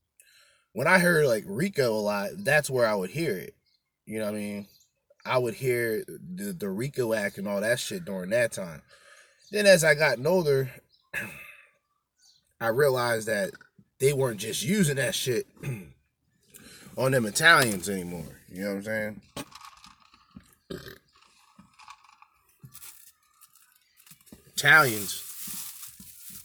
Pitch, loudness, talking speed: 140 Hz, -26 LUFS, 125 wpm